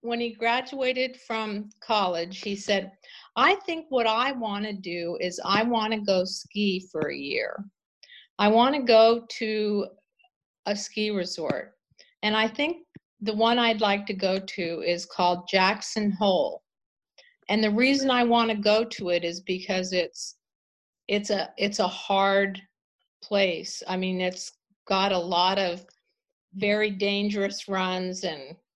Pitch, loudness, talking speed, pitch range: 205 Hz, -25 LUFS, 155 wpm, 185-225 Hz